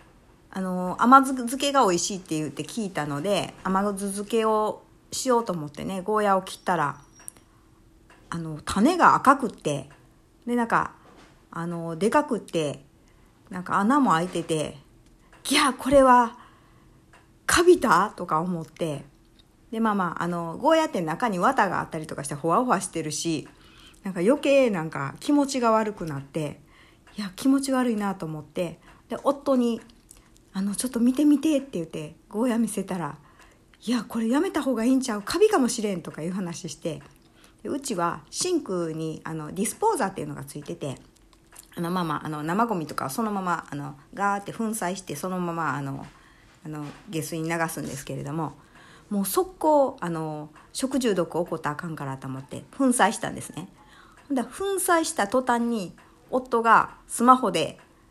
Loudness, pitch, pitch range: -25 LUFS, 190 Hz, 160-240 Hz